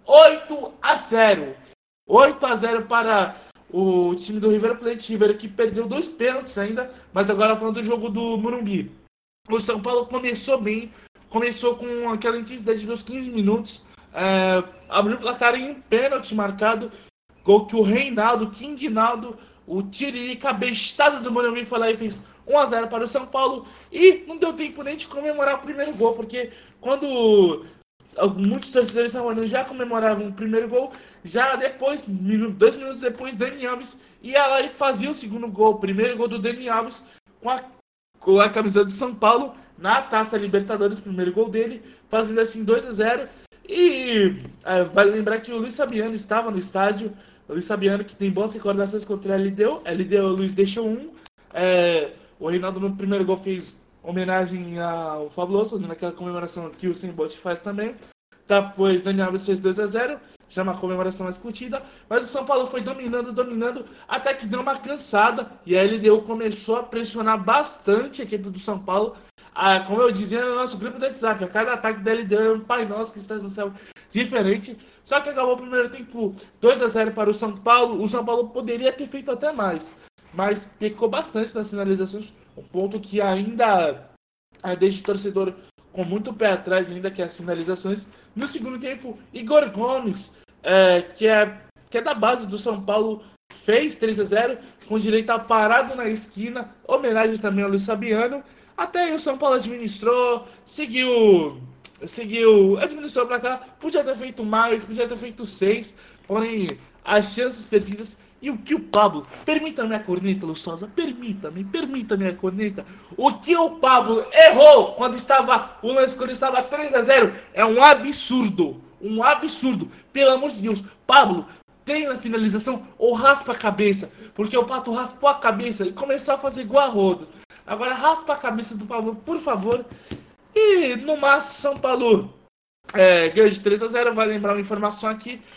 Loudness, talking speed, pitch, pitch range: -21 LUFS, 180 wpm, 225 Hz, 205-250 Hz